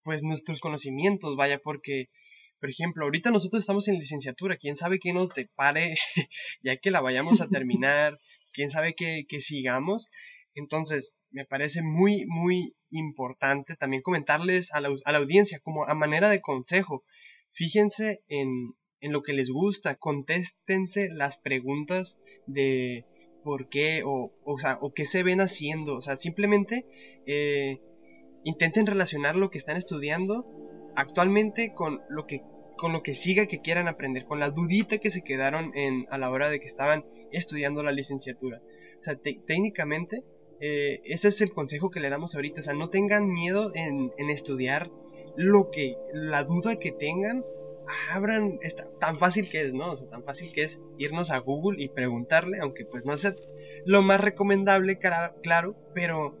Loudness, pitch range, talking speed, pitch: -28 LUFS, 140-190 Hz, 165 wpm, 155 Hz